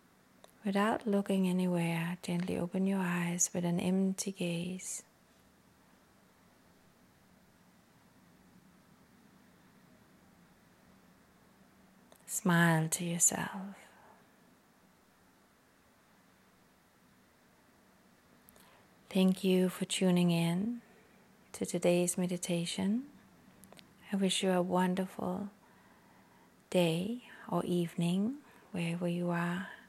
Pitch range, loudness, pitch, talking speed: 175-200 Hz, -33 LUFS, 185 Hz, 65 wpm